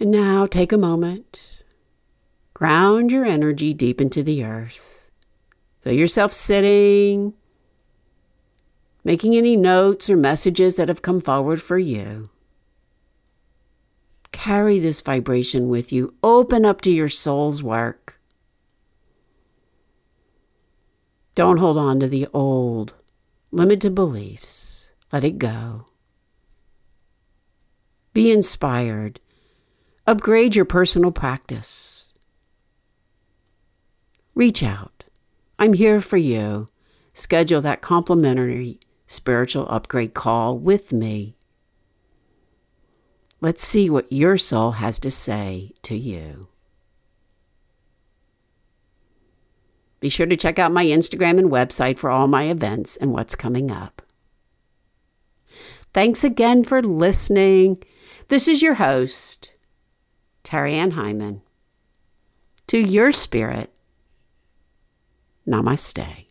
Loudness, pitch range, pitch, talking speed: -18 LUFS, 115-190 Hz, 140 Hz, 100 wpm